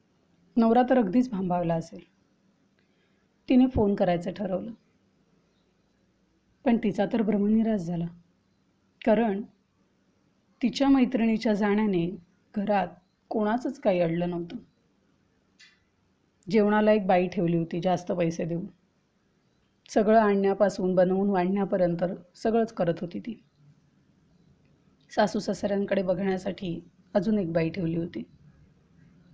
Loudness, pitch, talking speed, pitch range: -26 LUFS, 195 Hz, 95 wpm, 175-215 Hz